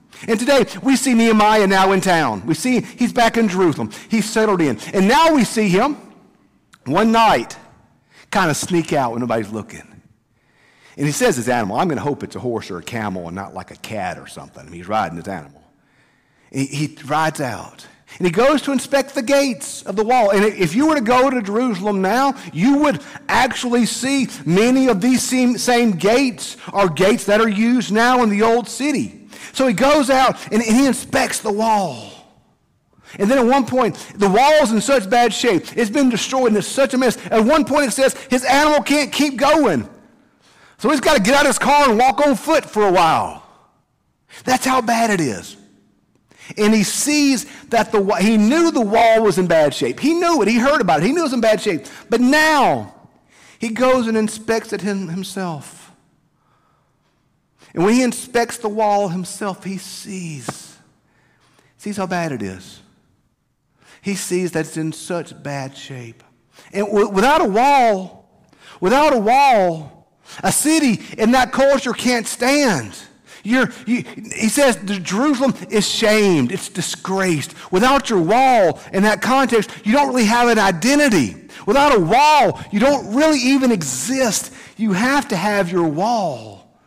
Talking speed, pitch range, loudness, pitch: 185 wpm, 180-255 Hz, -16 LUFS, 220 Hz